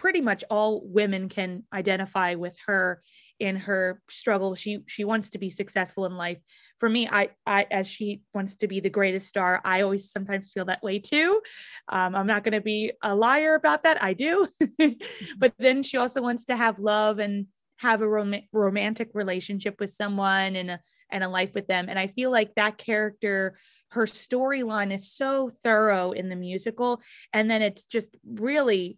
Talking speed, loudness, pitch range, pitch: 190 wpm, -26 LUFS, 195-225 Hz, 205 Hz